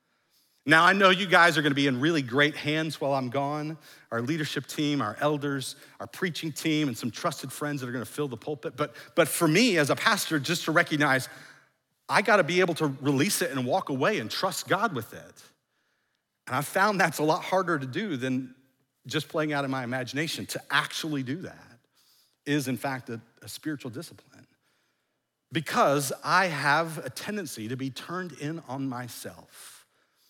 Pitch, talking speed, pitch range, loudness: 145 Hz, 195 wpm, 130-160 Hz, -27 LUFS